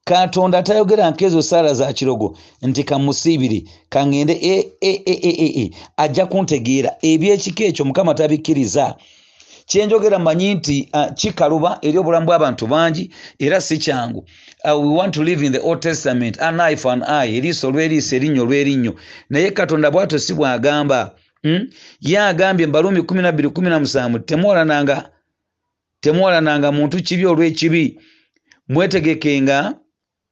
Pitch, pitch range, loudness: 155 Hz, 140-180 Hz, -16 LUFS